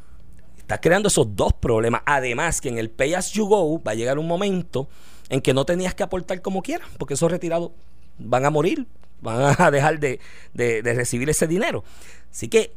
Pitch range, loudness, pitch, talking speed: 120-185 Hz, -22 LUFS, 160 Hz, 200 wpm